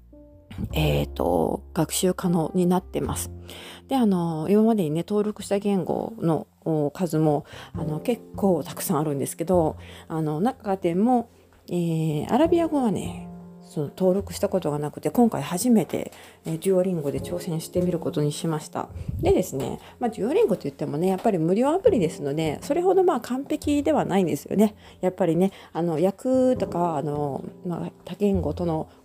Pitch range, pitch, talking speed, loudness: 150-205 Hz, 180 Hz, 335 characters per minute, -24 LUFS